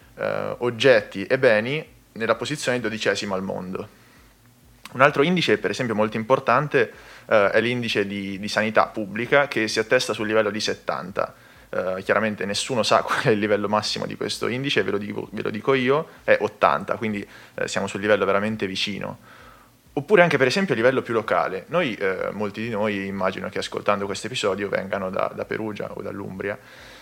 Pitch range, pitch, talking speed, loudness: 105-130 Hz, 110 Hz, 180 wpm, -23 LUFS